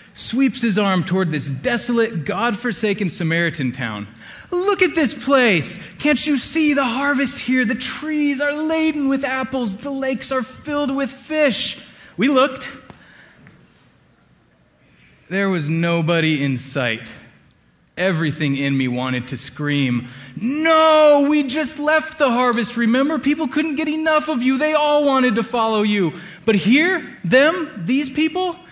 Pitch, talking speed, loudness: 245 Hz, 145 wpm, -19 LUFS